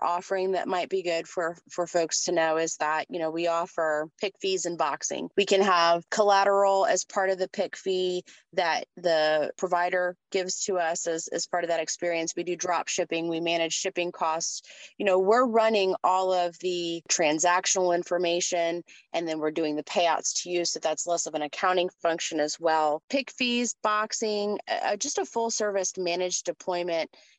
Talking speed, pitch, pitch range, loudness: 190 wpm, 175 Hz, 165-190 Hz, -27 LUFS